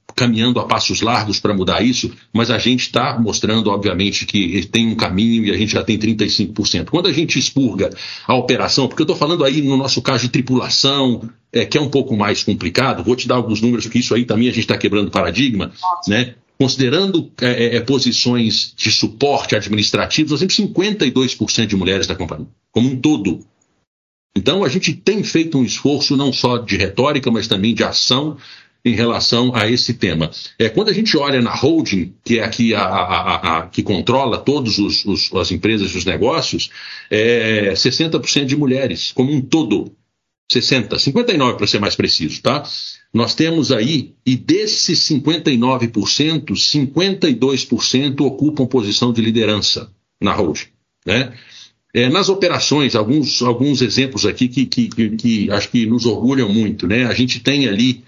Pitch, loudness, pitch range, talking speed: 120 Hz, -16 LUFS, 110-135 Hz, 175 wpm